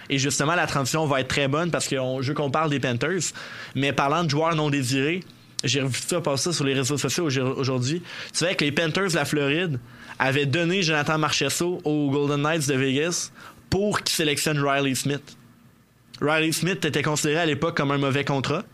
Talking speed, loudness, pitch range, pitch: 200 wpm, -24 LUFS, 140-160 Hz, 145 Hz